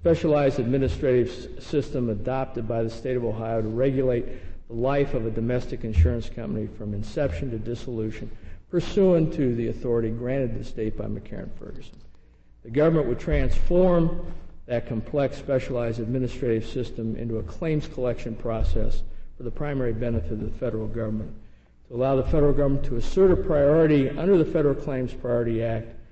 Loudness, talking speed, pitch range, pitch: -25 LUFS, 160 wpm, 110-135 Hz, 120 Hz